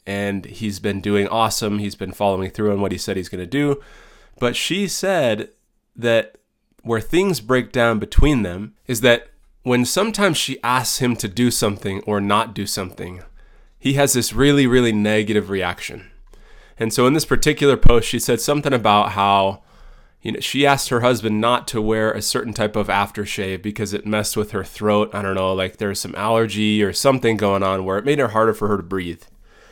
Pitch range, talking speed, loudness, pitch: 100-125 Hz, 200 wpm, -19 LUFS, 110 Hz